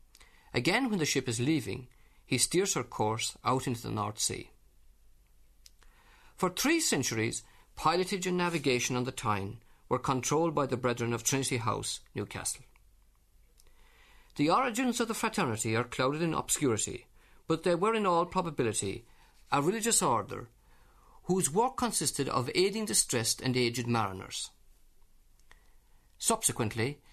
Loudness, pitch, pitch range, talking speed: -30 LUFS, 130 Hz, 110-180 Hz, 135 wpm